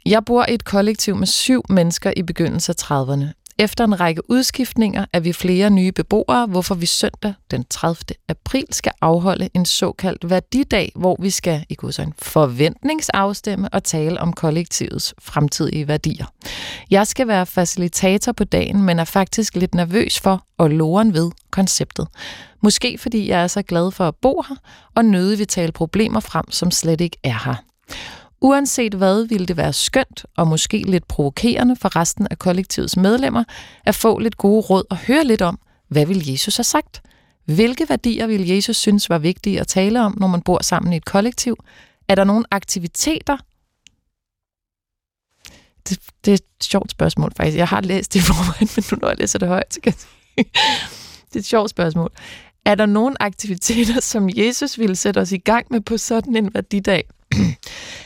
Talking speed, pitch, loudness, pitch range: 180 wpm, 195 Hz, -18 LUFS, 175-225 Hz